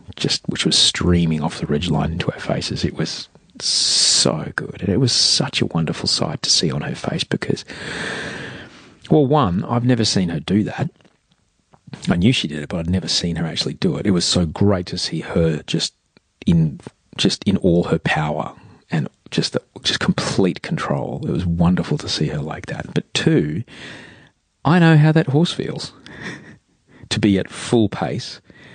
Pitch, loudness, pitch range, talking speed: 90 Hz, -19 LUFS, 80-120 Hz, 190 wpm